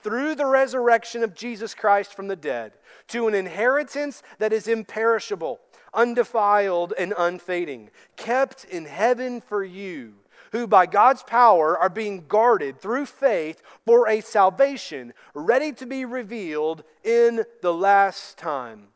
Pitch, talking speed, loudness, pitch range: 225 Hz, 135 wpm, -22 LUFS, 195-245 Hz